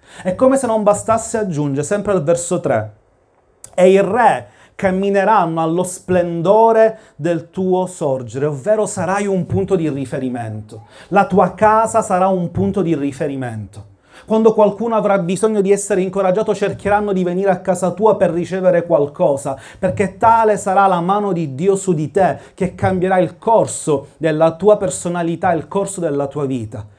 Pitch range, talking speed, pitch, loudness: 155-200 Hz, 160 wpm, 185 Hz, -16 LUFS